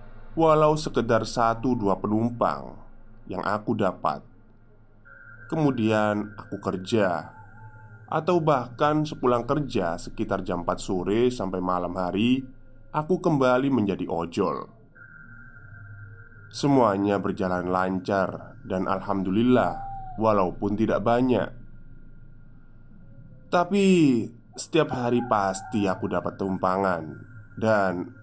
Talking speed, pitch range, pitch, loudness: 90 wpm, 100-130 Hz, 110 Hz, -25 LUFS